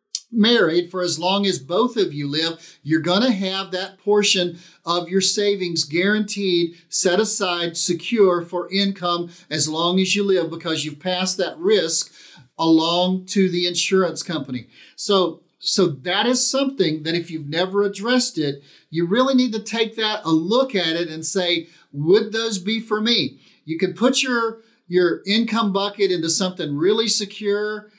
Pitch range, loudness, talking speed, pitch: 170-210 Hz, -20 LUFS, 165 wpm, 185 Hz